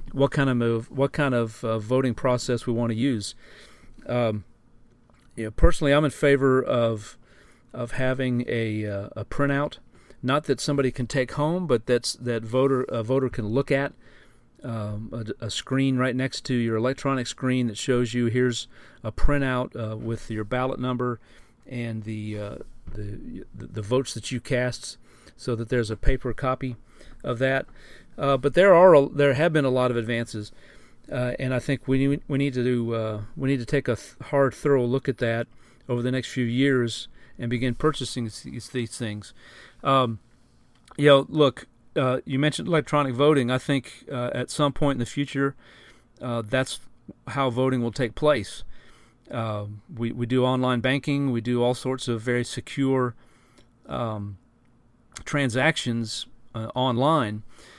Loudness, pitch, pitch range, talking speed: -25 LUFS, 125 Hz, 115-135 Hz, 175 wpm